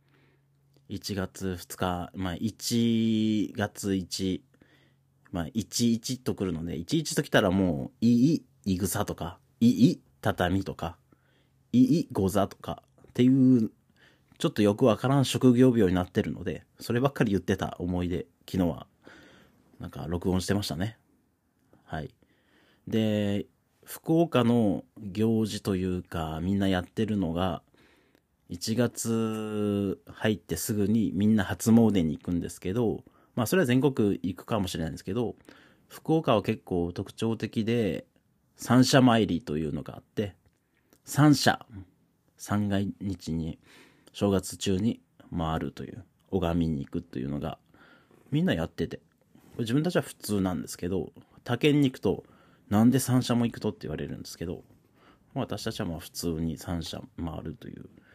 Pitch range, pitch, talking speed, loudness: 90-120 Hz, 105 Hz, 270 characters per minute, -28 LUFS